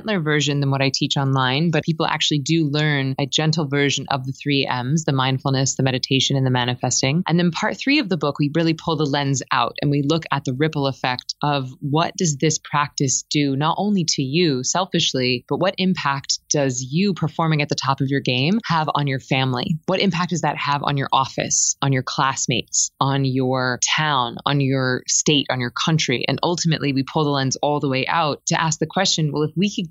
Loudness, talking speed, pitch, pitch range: -20 LUFS, 220 wpm, 145 Hz, 135-165 Hz